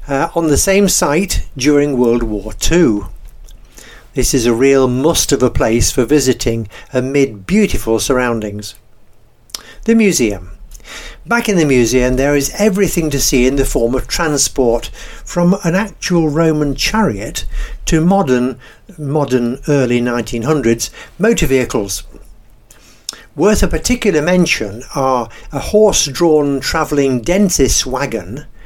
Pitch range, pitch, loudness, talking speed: 120-165 Hz, 140 Hz, -14 LUFS, 130 wpm